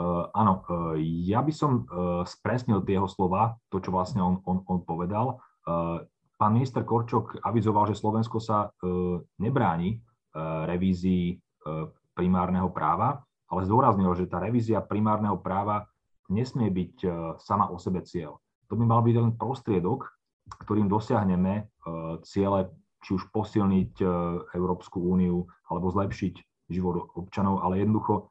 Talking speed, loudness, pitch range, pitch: 125 wpm, -28 LUFS, 90-110 Hz, 95 Hz